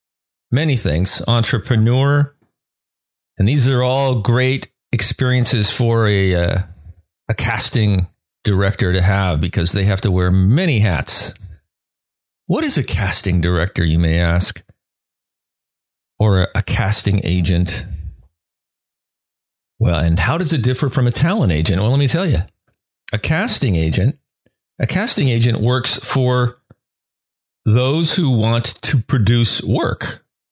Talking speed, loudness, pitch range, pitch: 130 wpm, -16 LUFS, 90-125 Hz, 105 Hz